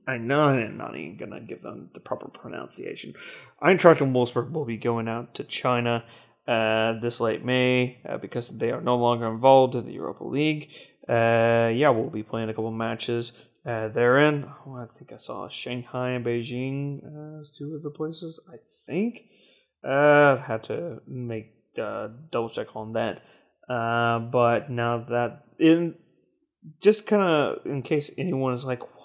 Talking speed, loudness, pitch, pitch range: 175 wpm, -25 LUFS, 125 Hz, 115-145 Hz